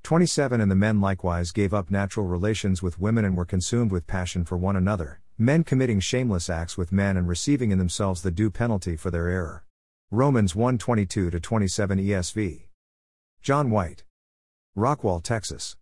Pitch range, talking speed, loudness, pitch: 90-110 Hz, 165 wpm, -25 LUFS, 95 Hz